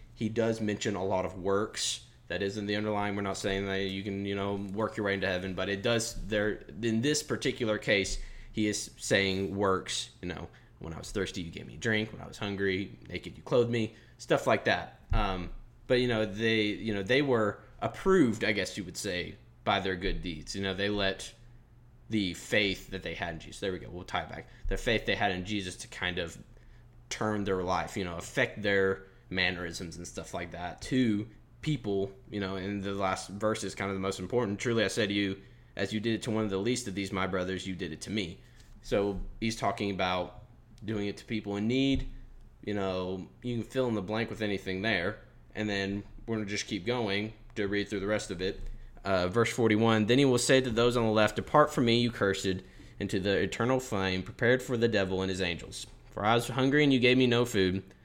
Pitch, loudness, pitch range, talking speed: 100 Hz, -31 LUFS, 95-115 Hz, 235 wpm